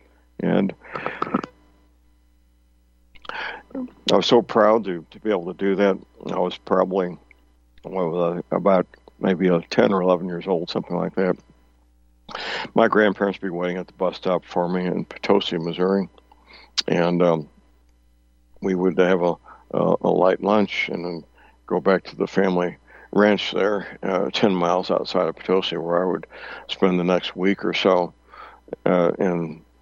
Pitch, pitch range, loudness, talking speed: 90 Hz, 60-95 Hz, -22 LUFS, 155 wpm